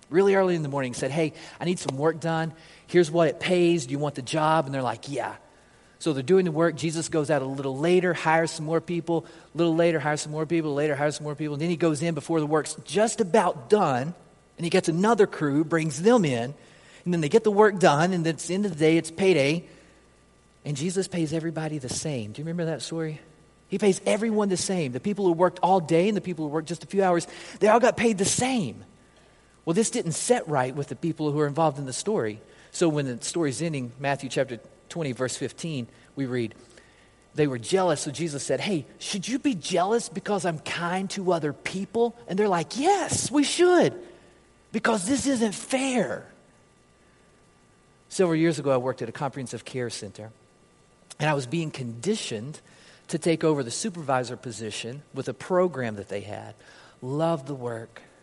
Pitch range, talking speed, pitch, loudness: 140-185 Hz, 215 wpm, 165 Hz, -25 LUFS